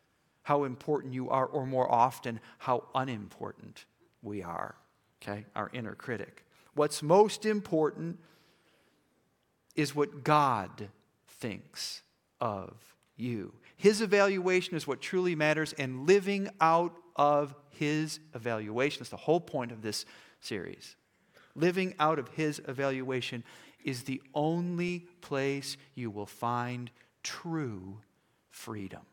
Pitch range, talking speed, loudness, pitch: 120-160 Hz, 115 wpm, -32 LUFS, 145 Hz